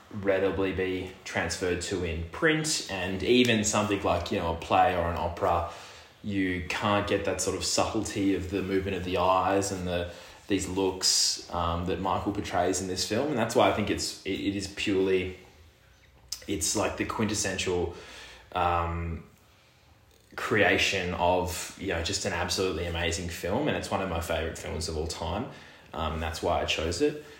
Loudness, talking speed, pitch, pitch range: -28 LUFS, 175 wpm, 95 Hz, 85-100 Hz